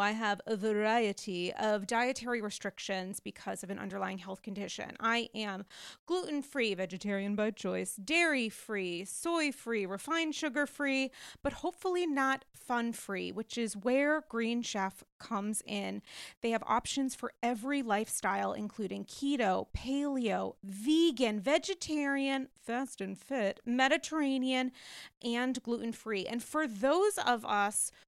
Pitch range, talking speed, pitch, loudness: 205-275 Hz, 135 wpm, 235 Hz, -34 LUFS